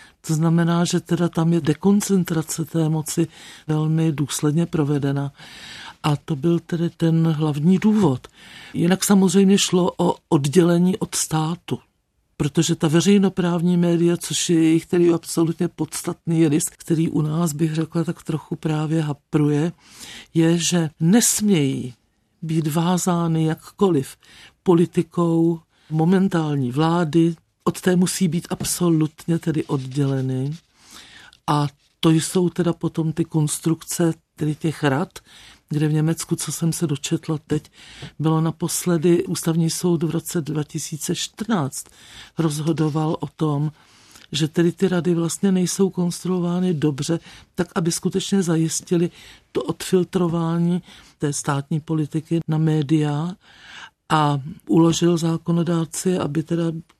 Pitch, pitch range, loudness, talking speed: 165 Hz, 155-175 Hz, -21 LUFS, 120 wpm